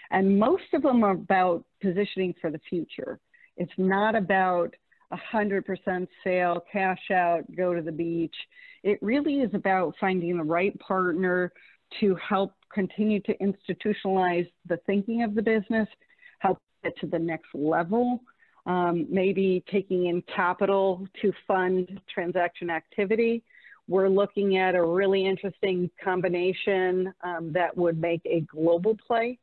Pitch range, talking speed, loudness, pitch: 175-205 Hz, 140 wpm, -26 LUFS, 190 Hz